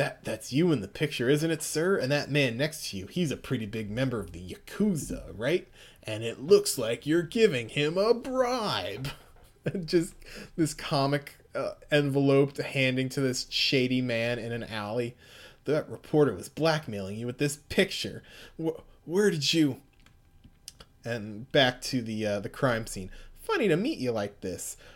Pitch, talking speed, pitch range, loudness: 140 Hz, 175 wpm, 115-160 Hz, -28 LUFS